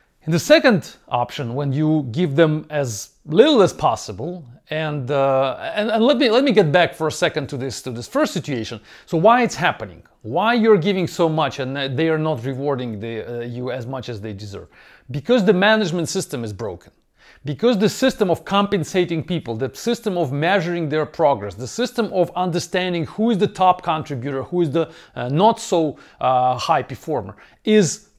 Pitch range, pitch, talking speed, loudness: 135-190 Hz, 160 Hz, 190 wpm, -19 LUFS